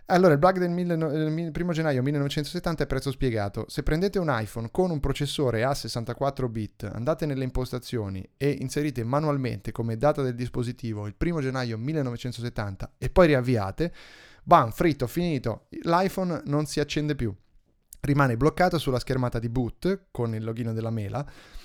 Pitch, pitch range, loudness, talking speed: 135 Hz, 120-155 Hz, -27 LUFS, 155 wpm